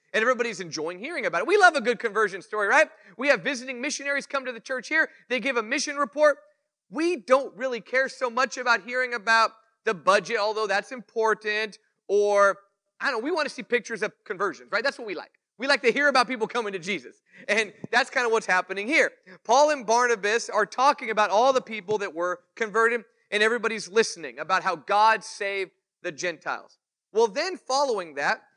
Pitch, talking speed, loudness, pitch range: 230 Hz, 205 wpm, -25 LUFS, 210-270 Hz